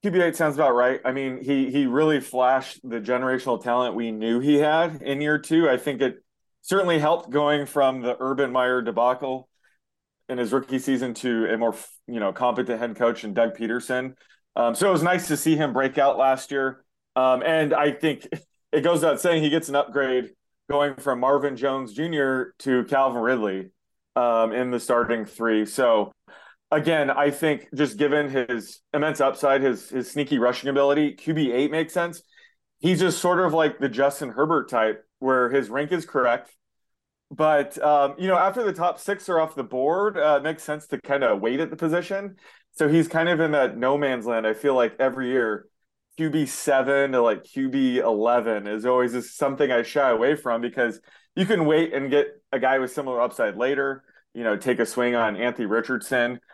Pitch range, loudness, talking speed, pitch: 125-155 Hz, -23 LUFS, 195 wpm, 135 Hz